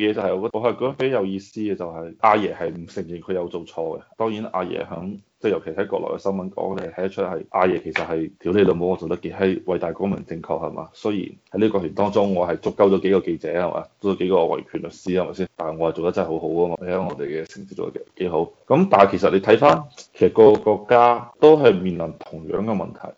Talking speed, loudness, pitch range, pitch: 375 characters per minute, -21 LUFS, 85-105 Hz, 95 Hz